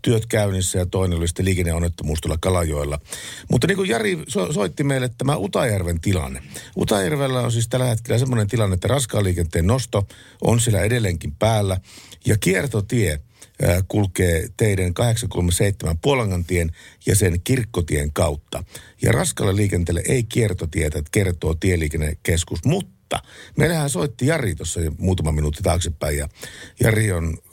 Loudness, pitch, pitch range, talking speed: -21 LUFS, 95 Hz, 85-115 Hz, 140 wpm